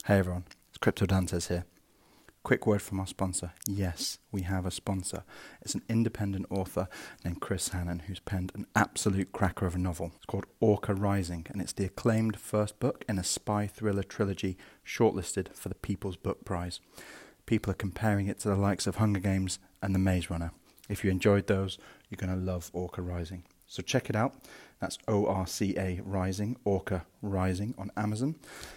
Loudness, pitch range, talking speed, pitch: -32 LUFS, 95-105 Hz, 190 wpm, 95 Hz